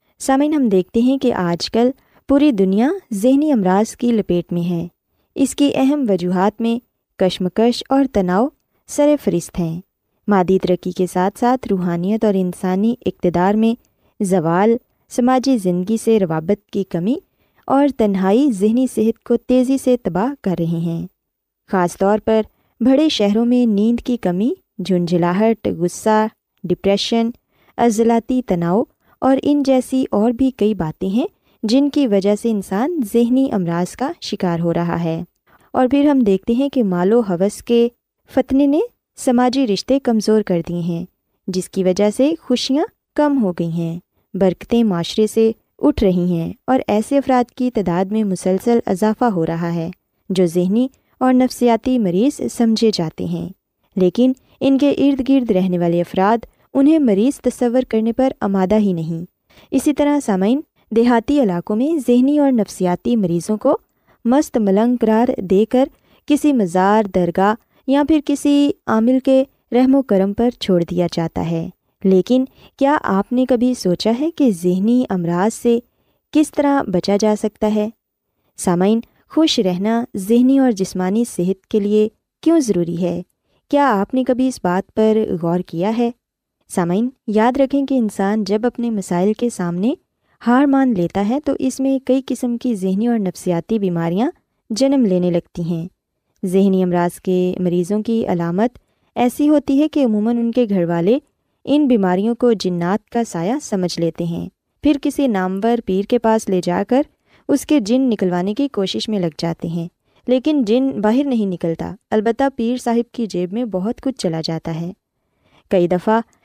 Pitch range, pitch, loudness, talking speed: 185-255 Hz, 220 Hz, -17 LUFS, 165 wpm